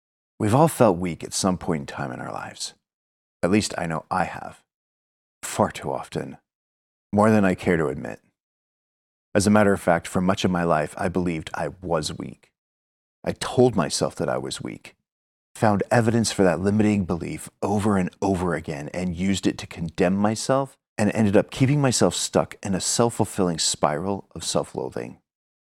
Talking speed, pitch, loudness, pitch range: 185 wpm, 95 Hz, -23 LUFS, 80-105 Hz